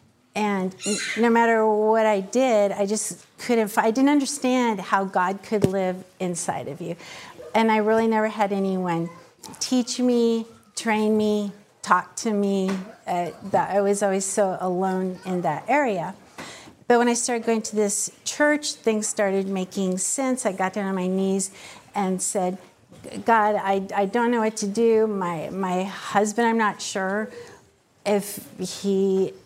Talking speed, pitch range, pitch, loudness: 160 wpm, 190-225 Hz, 205 Hz, -23 LUFS